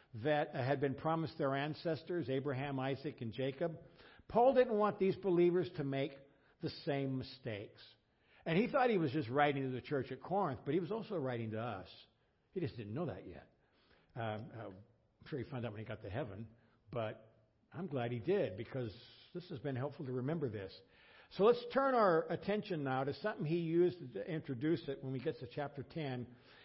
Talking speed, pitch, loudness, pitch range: 200 wpm, 140 Hz, -38 LUFS, 120-165 Hz